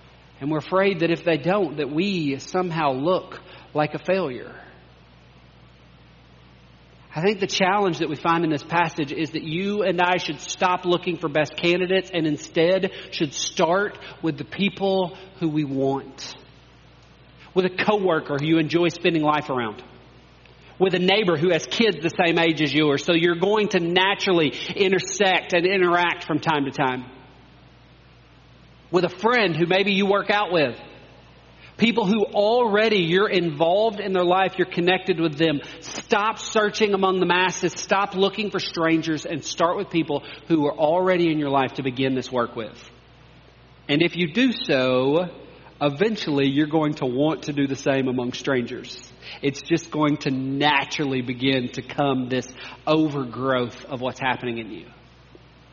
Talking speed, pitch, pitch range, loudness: 165 wpm, 160 Hz, 135-185 Hz, -22 LUFS